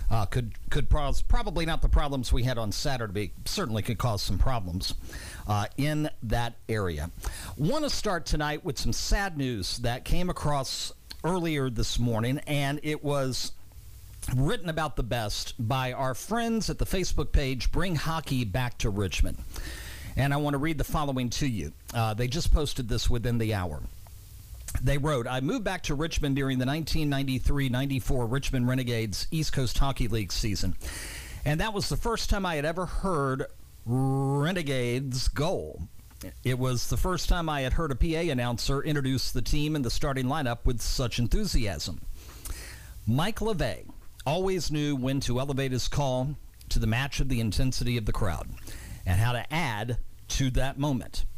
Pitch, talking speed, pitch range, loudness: 130 Hz, 170 wpm, 105-145 Hz, -30 LUFS